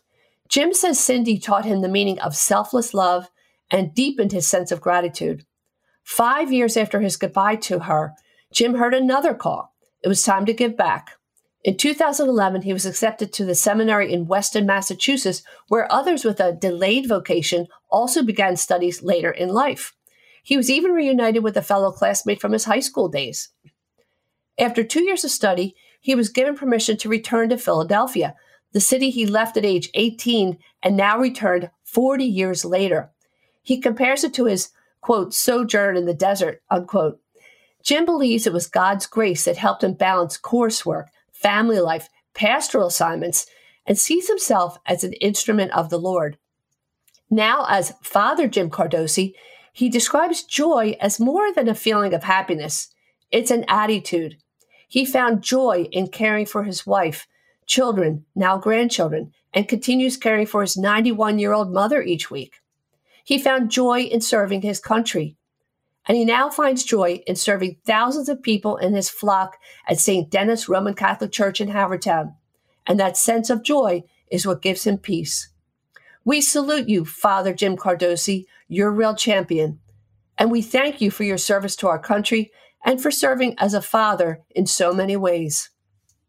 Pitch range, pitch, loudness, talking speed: 180-240 Hz, 205 Hz, -20 LUFS, 165 wpm